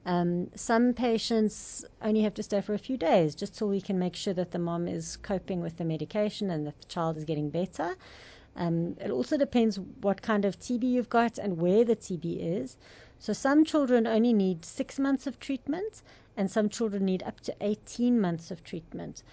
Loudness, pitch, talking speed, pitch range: -29 LUFS, 205 Hz, 205 wpm, 175-235 Hz